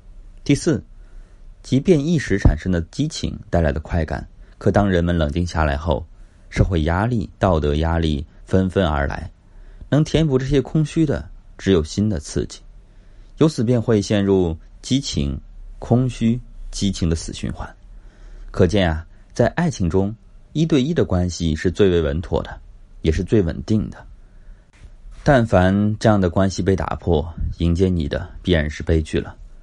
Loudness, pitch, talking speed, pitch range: -20 LUFS, 95 Hz, 225 characters per minute, 85-110 Hz